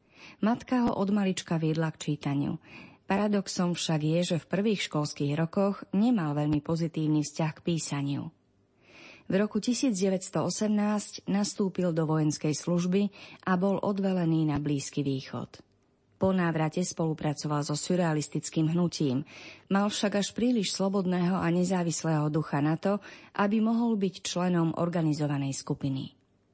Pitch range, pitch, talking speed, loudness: 150-195 Hz, 170 Hz, 125 wpm, -29 LUFS